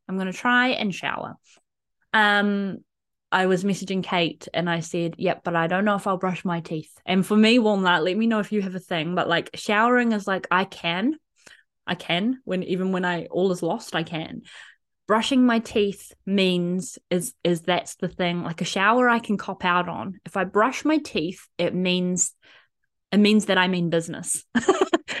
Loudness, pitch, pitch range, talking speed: -23 LUFS, 185 Hz, 175-215 Hz, 205 wpm